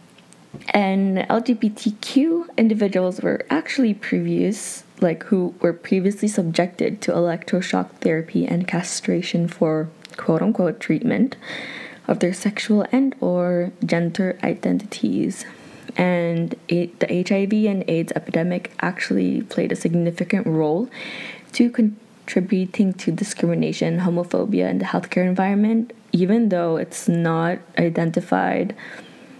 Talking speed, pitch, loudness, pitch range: 105 wpm, 185 Hz, -21 LUFS, 170-220 Hz